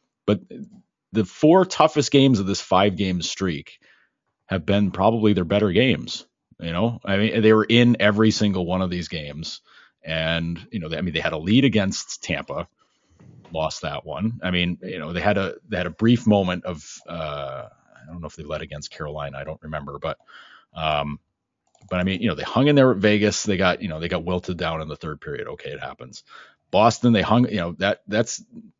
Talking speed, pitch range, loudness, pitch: 215 wpm, 85-110 Hz, -22 LUFS, 95 Hz